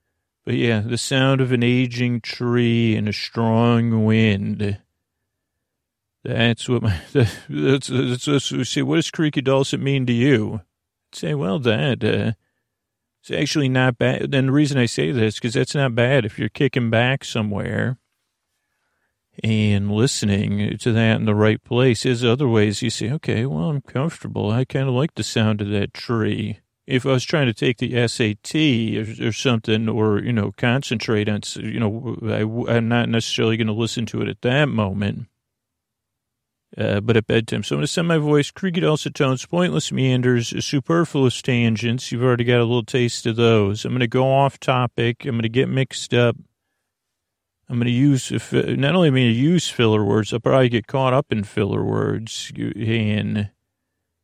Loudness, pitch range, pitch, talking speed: -20 LUFS, 110-130 Hz, 120 Hz, 175 wpm